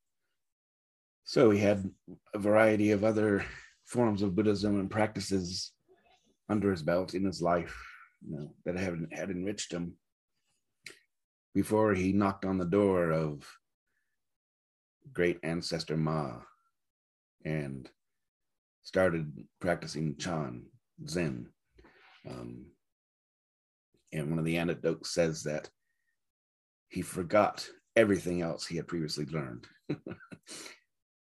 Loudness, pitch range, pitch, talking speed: -31 LUFS, 75-100 Hz, 85 Hz, 105 wpm